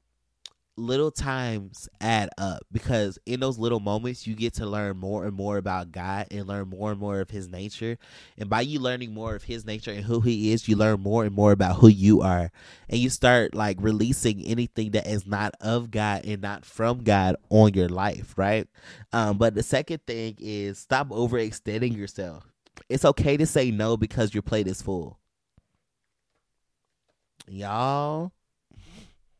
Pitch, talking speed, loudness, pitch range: 110 Hz, 175 wpm, -25 LUFS, 100-115 Hz